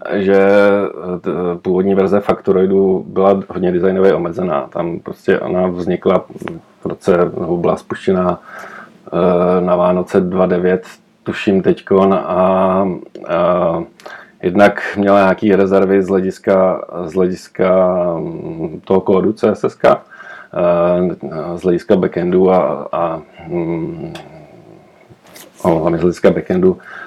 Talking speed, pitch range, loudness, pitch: 100 wpm, 90-100 Hz, -15 LUFS, 95 Hz